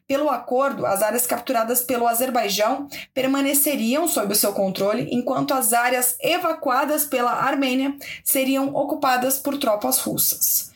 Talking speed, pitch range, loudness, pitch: 130 wpm, 245-285 Hz, -20 LUFS, 265 Hz